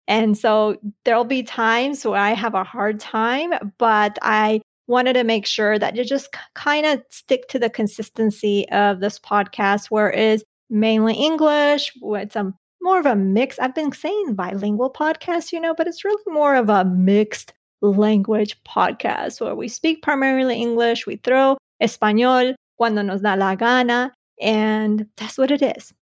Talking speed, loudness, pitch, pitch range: 175 wpm, -19 LUFS, 225 Hz, 210-265 Hz